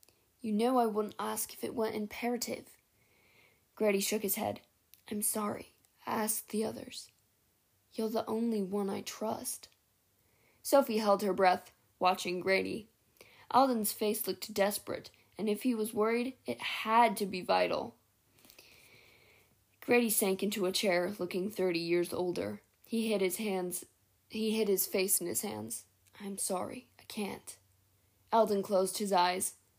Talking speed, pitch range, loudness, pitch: 145 wpm, 180-220 Hz, -33 LUFS, 205 Hz